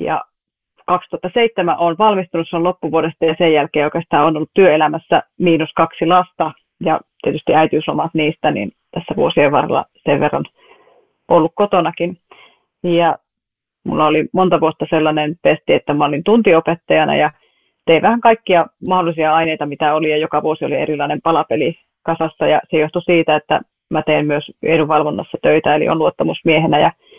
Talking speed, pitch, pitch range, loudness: 150 wpm, 165 Hz, 155-180 Hz, -15 LUFS